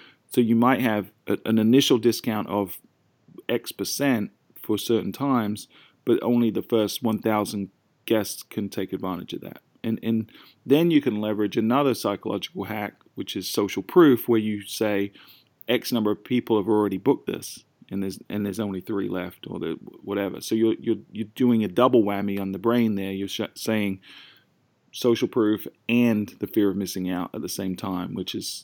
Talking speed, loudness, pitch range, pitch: 185 wpm, -25 LUFS, 100-115 Hz, 110 Hz